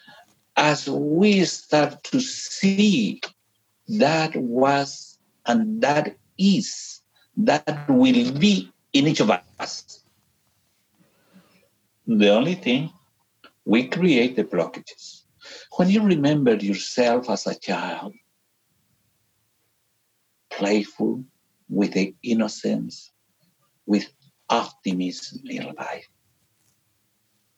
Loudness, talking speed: -22 LUFS, 85 wpm